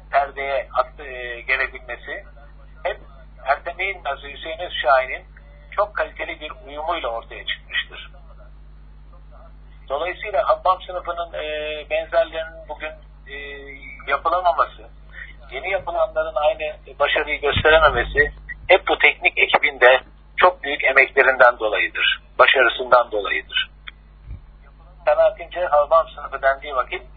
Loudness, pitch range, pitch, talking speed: -19 LUFS, 140-215 Hz, 160 Hz, 95 wpm